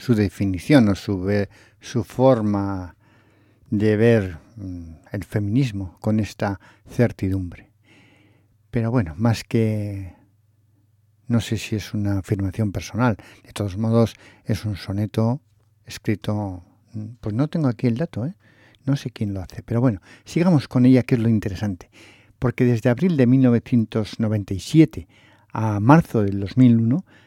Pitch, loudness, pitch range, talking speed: 110 Hz, -21 LUFS, 100-120 Hz, 135 wpm